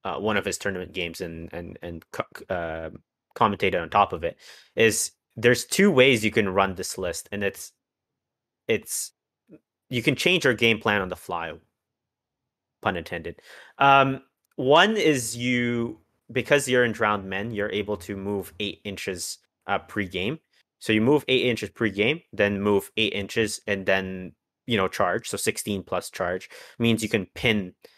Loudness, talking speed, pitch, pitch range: -24 LUFS, 170 wpm, 105 Hz, 95-120 Hz